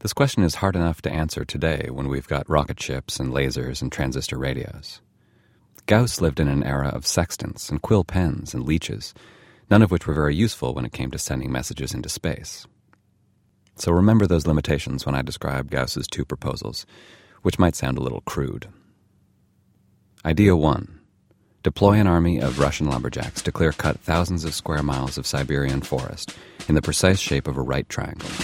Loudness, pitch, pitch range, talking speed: -23 LUFS, 80 Hz, 70-100 Hz, 180 wpm